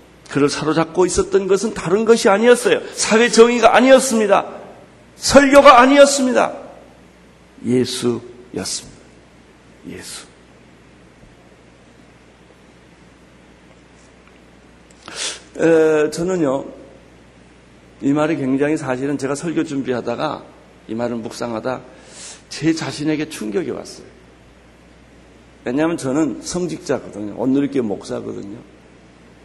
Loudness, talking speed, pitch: -16 LUFS, 220 characters per minute, 140 Hz